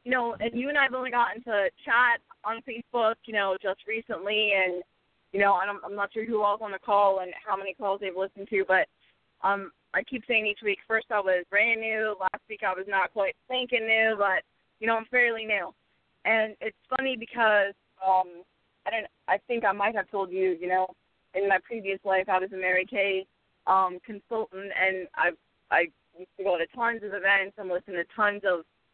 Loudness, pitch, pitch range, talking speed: -27 LUFS, 200 Hz, 190-225 Hz, 220 wpm